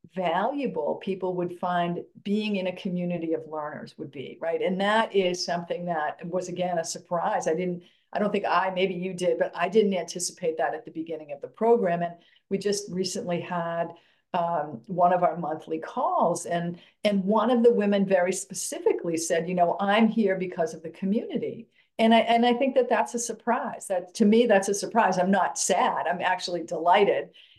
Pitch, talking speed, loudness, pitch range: 185 Hz, 200 wpm, -26 LUFS, 175-210 Hz